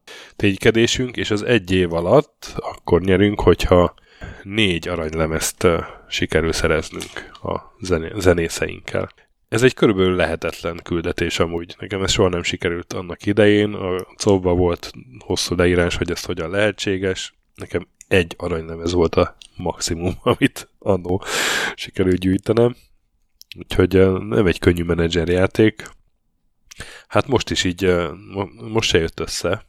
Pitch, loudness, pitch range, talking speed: 90 Hz, -19 LUFS, 85-105 Hz, 125 wpm